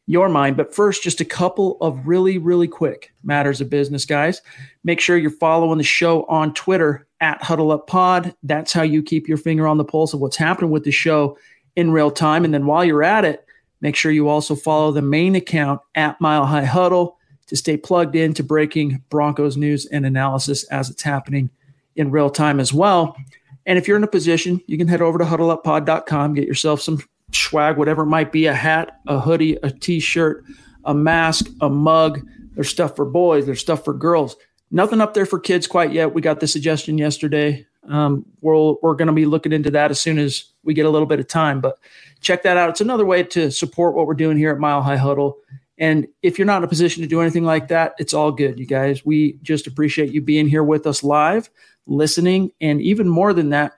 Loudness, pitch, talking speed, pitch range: -18 LUFS, 155 Hz, 220 wpm, 145-170 Hz